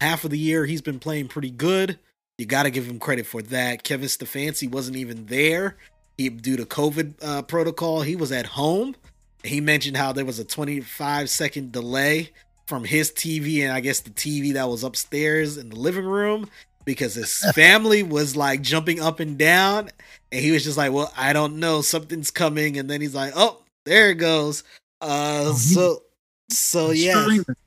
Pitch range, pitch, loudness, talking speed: 135-160 Hz, 150 Hz, -21 LUFS, 190 wpm